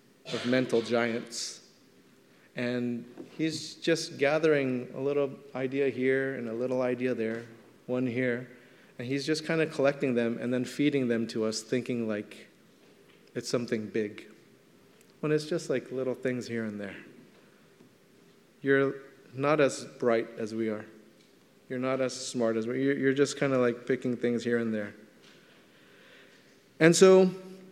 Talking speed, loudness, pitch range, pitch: 155 wpm, -29 LUFS, 115-135 Hz, 125 Hz